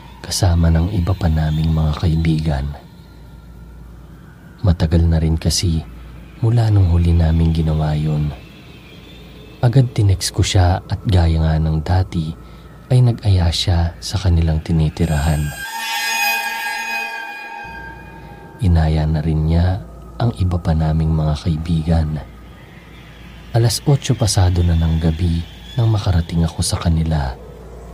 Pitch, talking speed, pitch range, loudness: 85 Hz, 115 wpm, 80-95 Hz, -17 LUFS